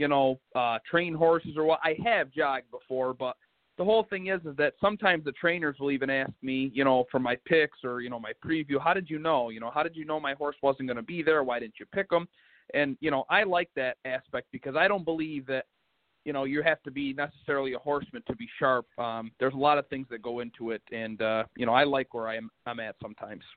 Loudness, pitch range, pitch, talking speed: -29 LUFS, 125-160 Hz, 140 Hz, 260 wpm